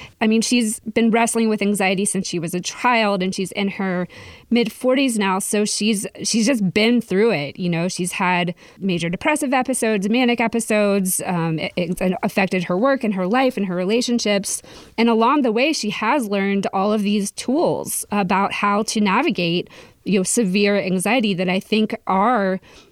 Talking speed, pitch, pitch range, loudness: 185 wpm, 205 Hz, 190-230 Hz, -19 LUFS